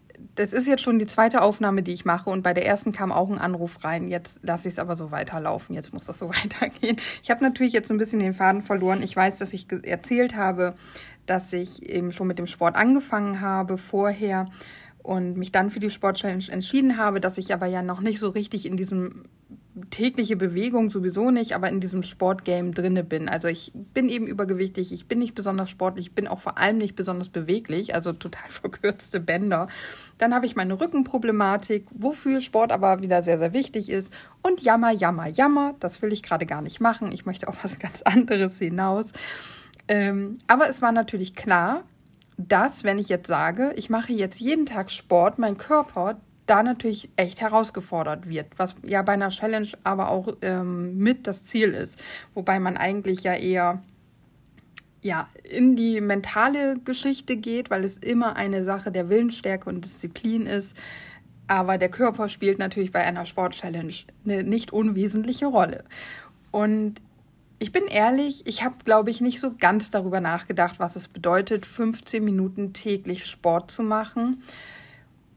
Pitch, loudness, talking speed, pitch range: 200 Hz, -24 LUFS, 180 wpm, 185-225 Hz